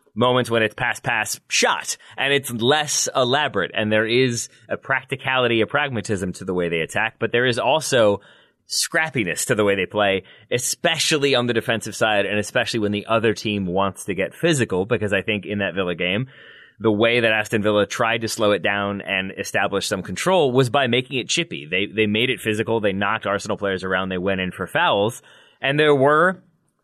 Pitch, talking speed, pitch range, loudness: 110 Hz, 205 wpm, 100-130 Hz, -20 LUFS